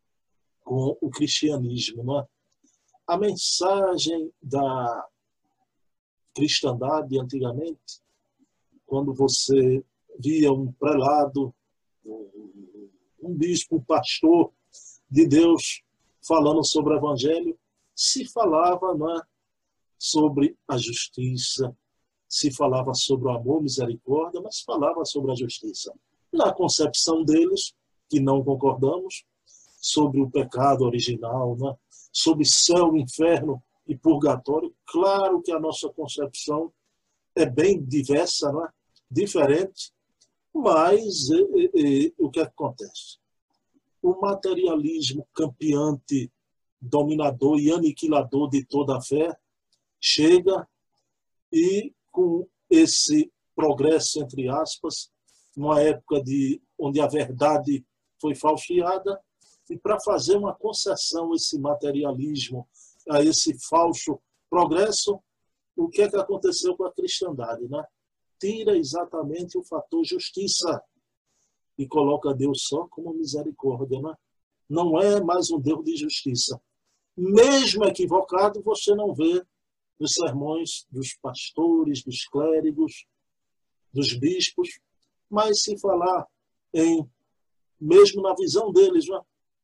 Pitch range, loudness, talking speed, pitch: 140-200 Hz, -23 LUFS, 110 wpm, 155 Hz